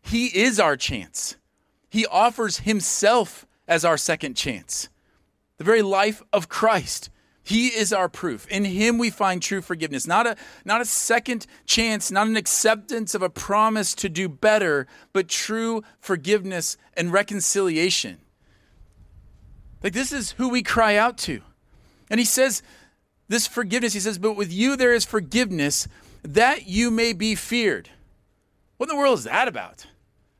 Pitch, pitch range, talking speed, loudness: 215 Hz, 185-230 Hz, 155 wpm, -22 LUFS